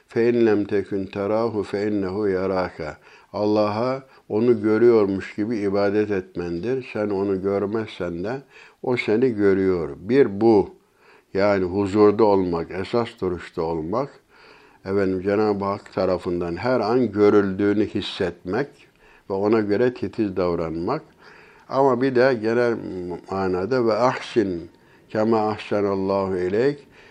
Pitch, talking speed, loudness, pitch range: 100 Hz, 110 wpm, -22 LUFS, 95-115 Hz